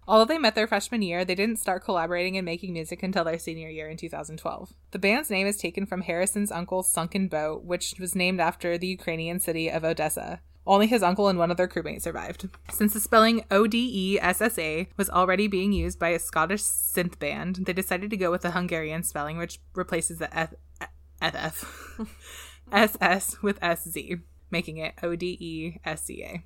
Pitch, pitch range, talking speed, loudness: 180 Hz, 165-195 Hz, 180 wpm, -26 LUFS